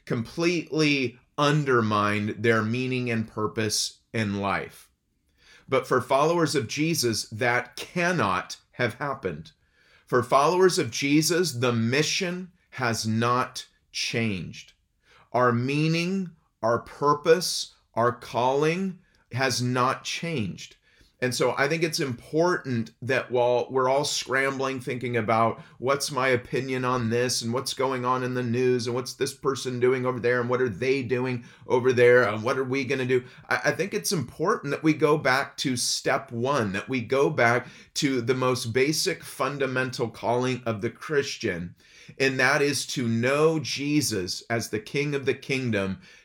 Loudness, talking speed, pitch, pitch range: -25 LUFS, 150 wpm, 130 Hz, 120-145 Hz